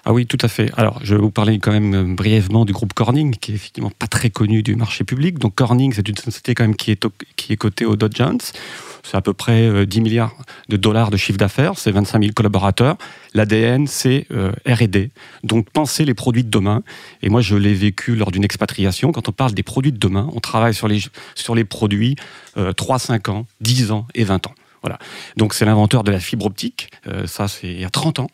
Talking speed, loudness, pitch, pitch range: 230 wpm, -17 LUFS, 110 Hz, 105-120 Hz